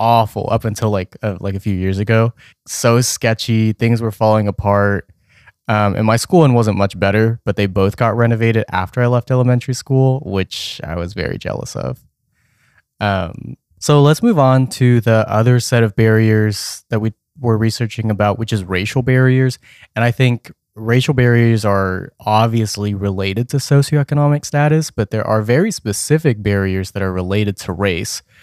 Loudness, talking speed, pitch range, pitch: -16 LUFS, 170 wpm, 100-125 Hz, 110 Hz